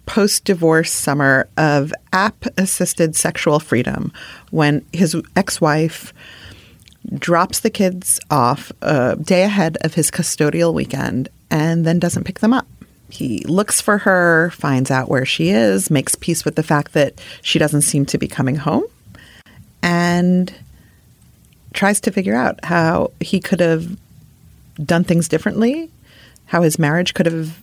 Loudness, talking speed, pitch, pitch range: -17 LUFS, 150 wpm, 170 Hz, 155-190 Hz